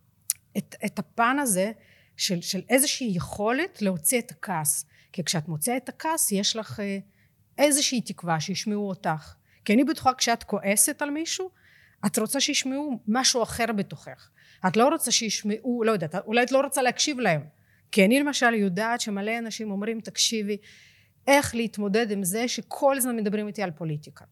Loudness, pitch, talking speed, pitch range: -25 LUFS, 215 Hz, 160 wpm, 190-250 Hz